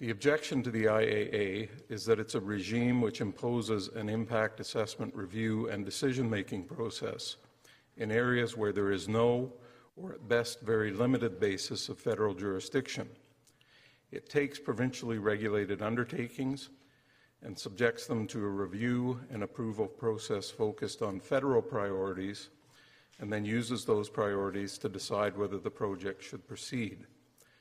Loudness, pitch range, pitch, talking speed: -34 LUFS, 105-125 Hz, 115 Hz, 140 wpm